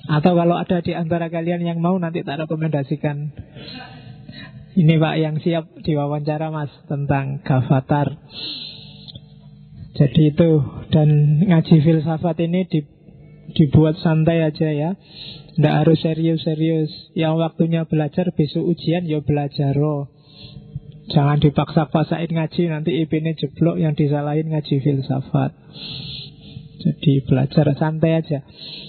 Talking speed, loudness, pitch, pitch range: 120 wpm, -19 LUFS, 155 Hz, 150-165 Hz